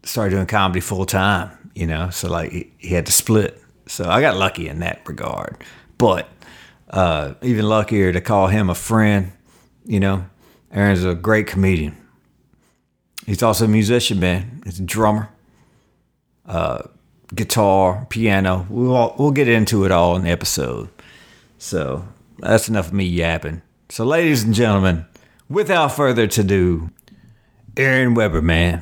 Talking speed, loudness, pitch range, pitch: 150 wpm, -18 LUFS, 90-110 Hz, 100 Hz